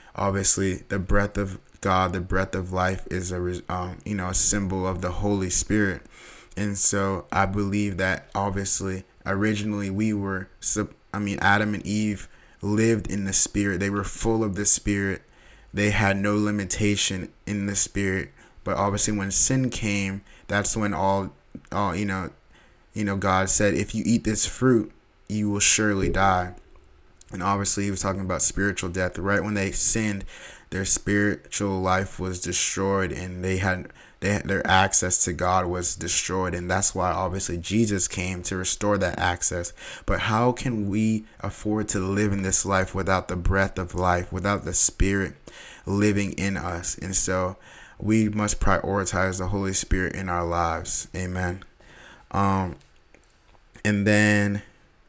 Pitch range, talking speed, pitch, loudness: 90-100 Hz, 160 wpm, 95 Hz, -24 LUFS